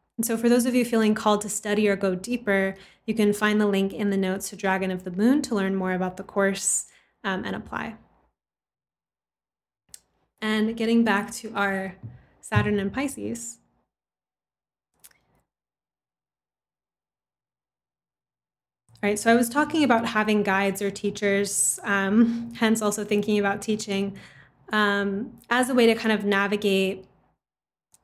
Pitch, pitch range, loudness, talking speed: 205 Hz, 195-225 Hz, -24 LUFS, 145 wpm